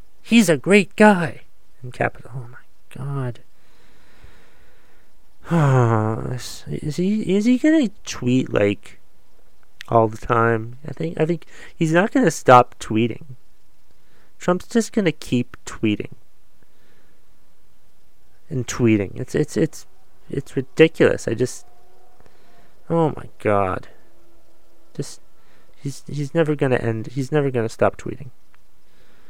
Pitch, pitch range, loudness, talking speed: 135 Hz, 115-165 Hz, -20 LUFS, 115 wpm